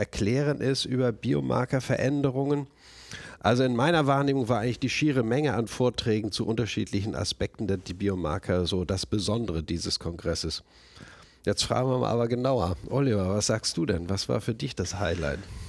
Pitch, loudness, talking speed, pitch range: 110 Hz, -27 LUFS, 165 wpm, 90-130 Hz